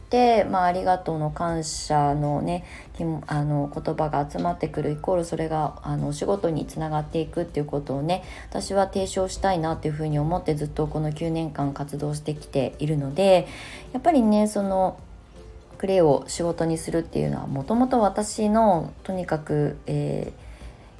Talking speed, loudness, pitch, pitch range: 325 characters per minute, -25 LUFS, 155 Hz, 145-185 Hz